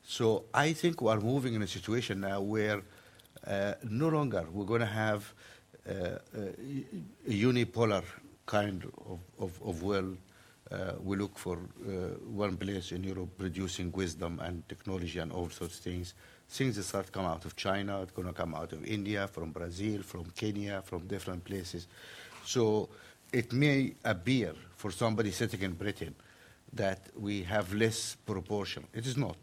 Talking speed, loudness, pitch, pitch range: 170 wpm, -35 LUFS, 100 Hz, 90-110 Hz